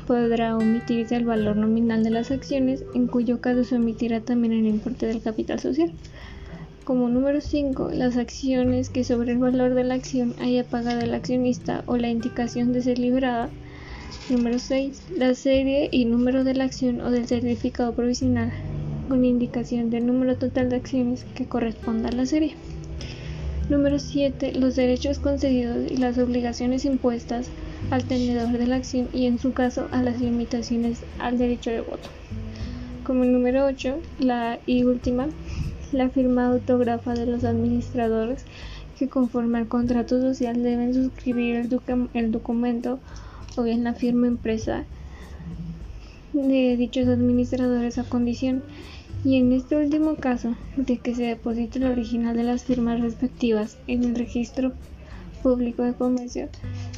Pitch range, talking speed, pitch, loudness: 235-255 Hz, 155 wpm, 245 Hz, -24 LUFS